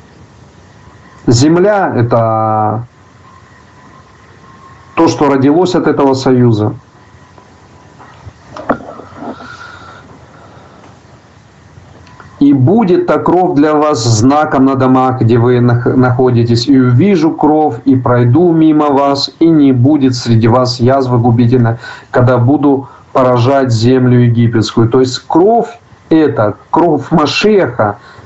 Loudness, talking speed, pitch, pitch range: -10 LUFS, 95 wpm, 125 Hz, 115-145 Hz